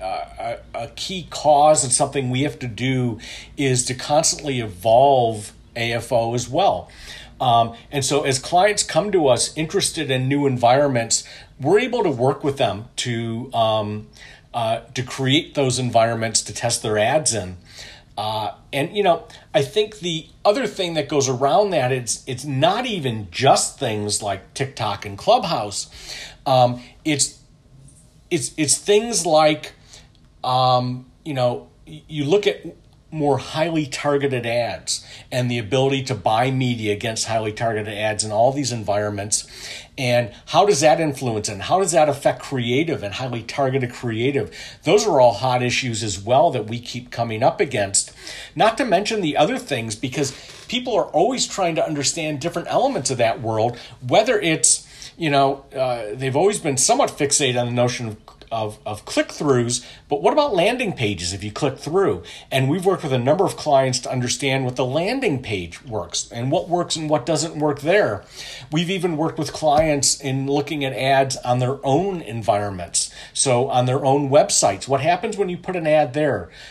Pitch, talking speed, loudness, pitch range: 135 Hz, 175 wpm, -20 LUFS, 115-150 Hz